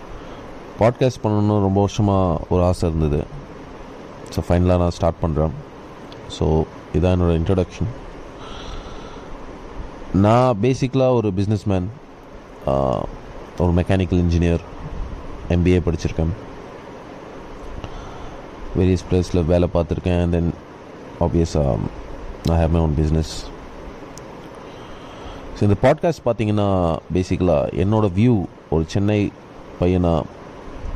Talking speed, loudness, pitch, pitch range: 90 wpm, -20 LUFS, 90 Hz, 85-105 Hz